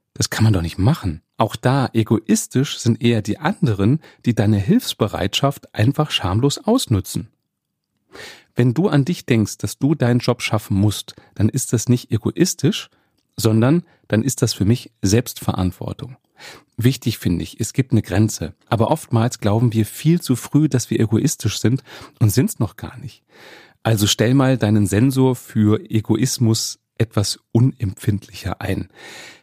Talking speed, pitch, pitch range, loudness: 155 wpm, 115 Hz, 105-130 Hz, -19 LUFS